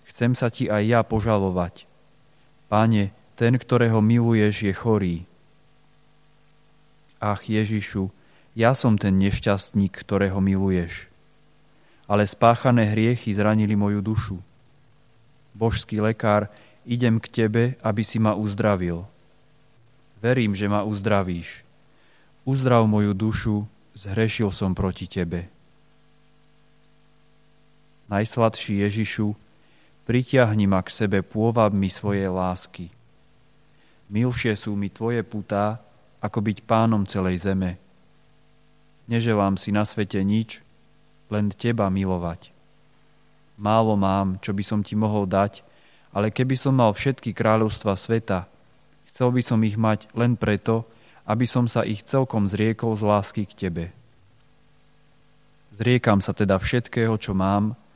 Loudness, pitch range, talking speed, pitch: -23 LUFS, 100-120 Hz, 115 wpm, 110 Hz